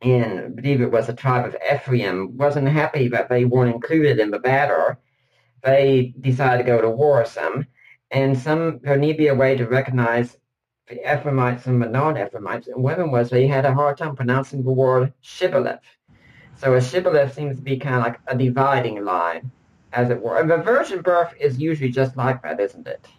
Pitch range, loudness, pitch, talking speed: 125-145 Hz, -20 LUFS, 130 Hz, 200 wpm